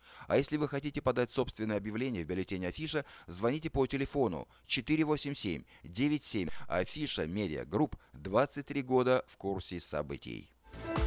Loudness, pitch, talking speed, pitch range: -34 LUFS, 130 Hz, 115 wpm, 100-145 Hz